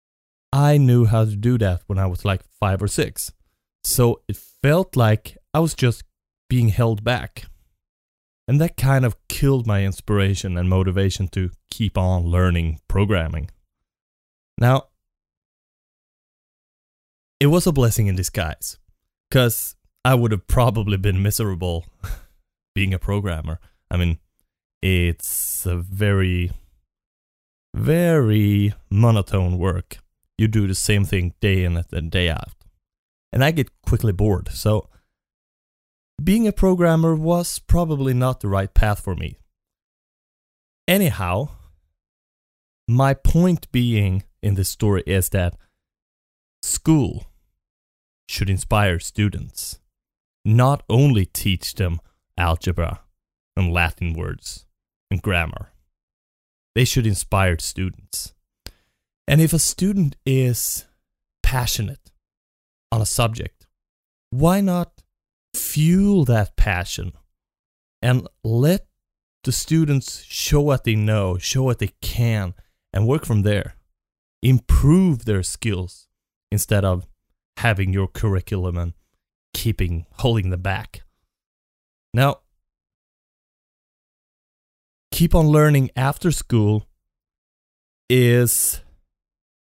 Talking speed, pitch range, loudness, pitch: 110 wpm, 85-120 Hz, -20 LUFS, 100 Hz